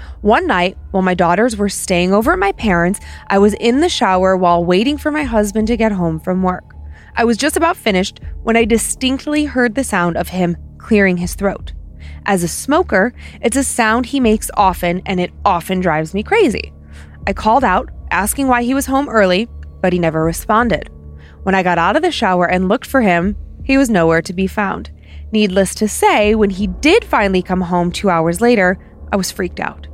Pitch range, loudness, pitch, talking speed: 175-230 Hz, -15 LUFS, 195 Hz, 205 wpm